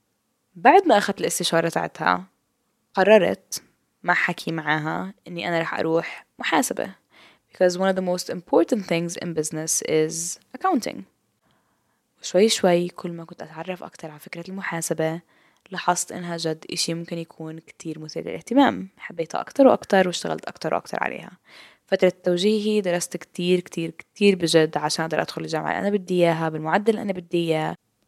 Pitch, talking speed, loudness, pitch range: 175 Hz, 150 wpm, -23 LUFS, 160-190 Hz